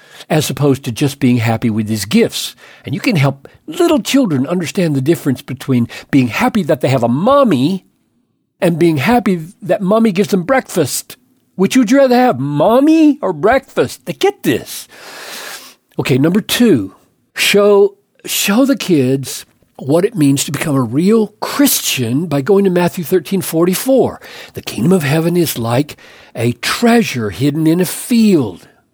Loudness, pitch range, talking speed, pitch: -13 LUFS, 140-220 Hz, 165 wpm, 175 Hz